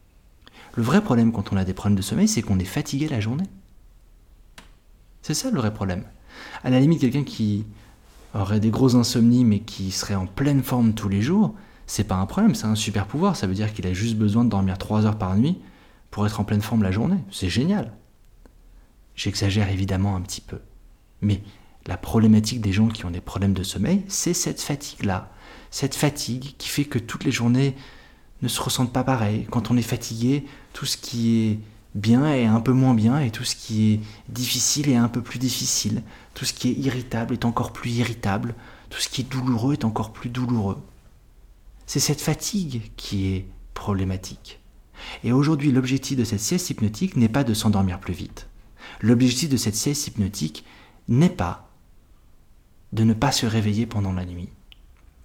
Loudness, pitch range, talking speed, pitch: -23 LUFS, 100-130 Hz, 195 wpm, 110 Hz